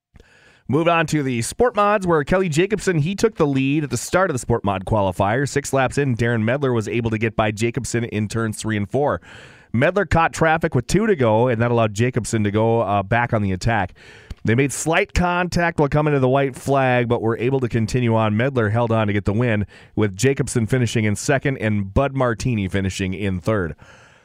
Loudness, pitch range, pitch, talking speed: -20 LUFS, 110-140 Hz, 120 Hz, 220 wpm